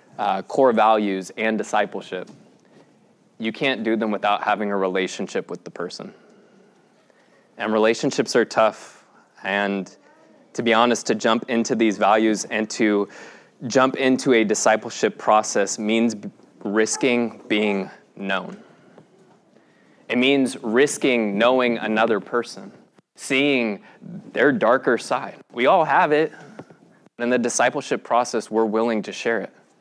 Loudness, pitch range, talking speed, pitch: -21 LUFS, 105-120 Hz, 130 wpm, 110 Hz